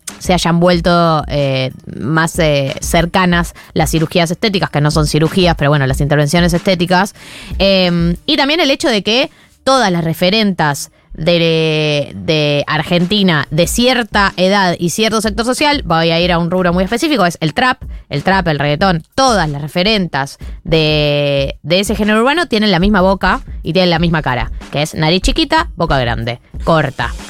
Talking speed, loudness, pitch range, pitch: 170 wpm, -13 LUFS, 155-195 Hz, 175 Hz